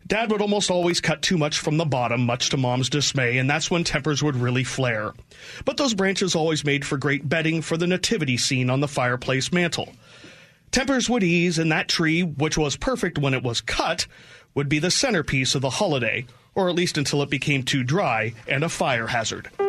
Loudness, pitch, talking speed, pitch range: -22 LUFS, 155 Hz, 210 wpm, 135-180 Hz